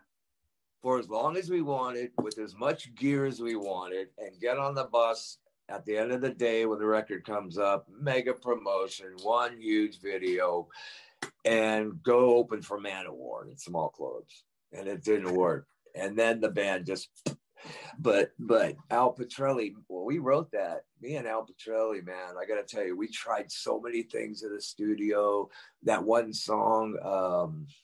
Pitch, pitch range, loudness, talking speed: 115 Hz, 105-135 Hz, -31 LUFS, 175 wpm